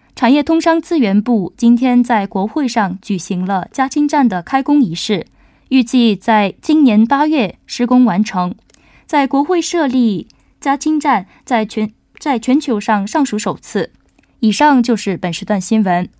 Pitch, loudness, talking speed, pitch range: 235 Hz, -14 LUFS, 230 characters per minute, 210-280 Hz